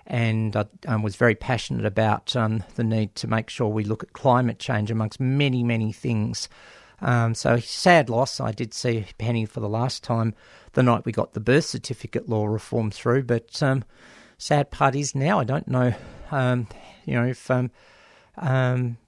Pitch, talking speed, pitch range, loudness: 120 Hz, 185 wpm, 110-130 Hz, -24 LUFS